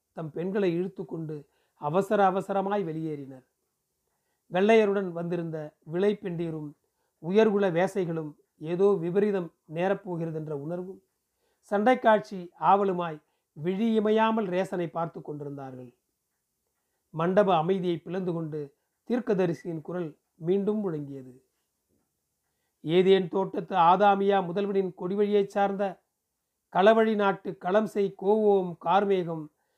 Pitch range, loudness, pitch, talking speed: 165-200 Hz, -27 LUFS, 185 Hz, 85 wpm